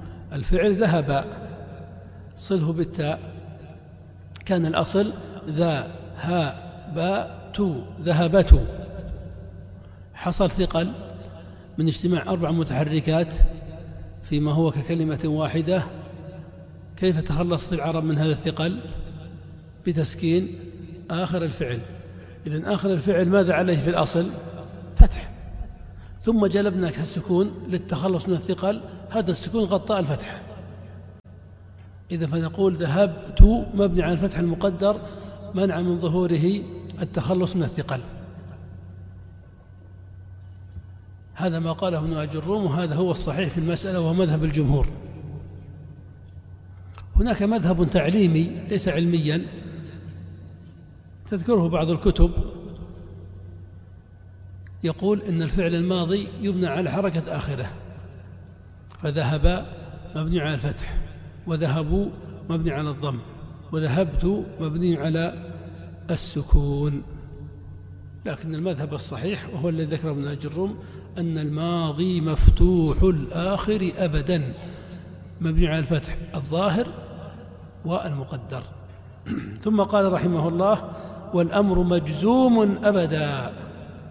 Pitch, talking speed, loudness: 160 Hz, 90 wpm, -24 LUFS